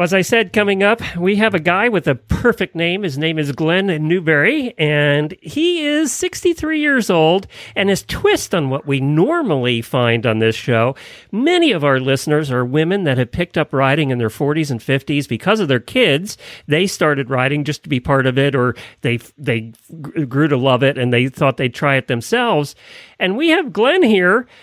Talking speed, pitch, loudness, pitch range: 200 wpm, 150 Hz, -16 LUFS, 135-190 Hz